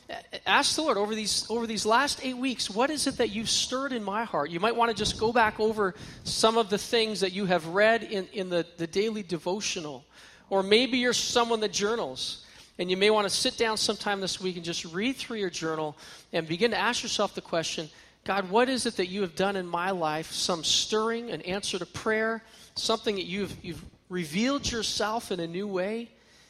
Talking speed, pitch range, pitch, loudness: 220 wpm, 180-225 Hz, 205 Hz, -28 LUFS